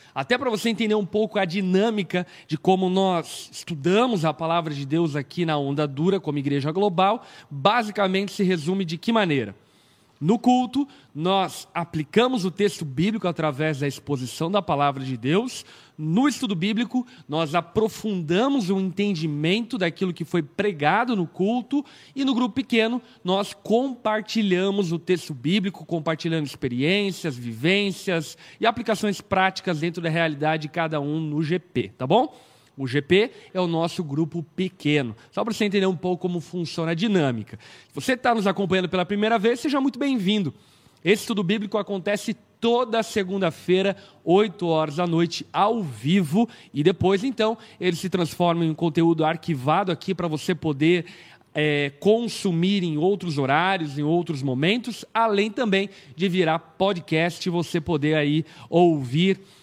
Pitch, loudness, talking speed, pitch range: 185 Hz, -24 LUFS, 155 wpm, 160-205 Hz